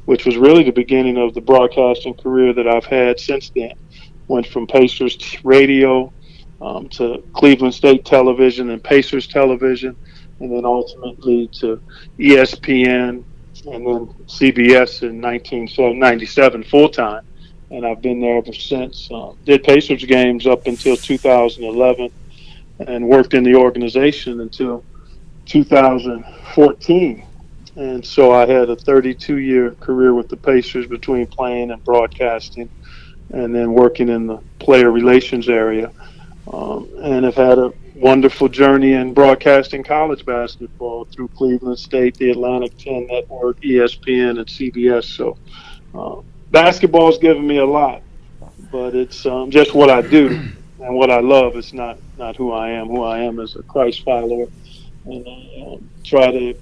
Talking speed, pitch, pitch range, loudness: 145 wpm, 125 Hz, 120-135 Hz, -14 LUFS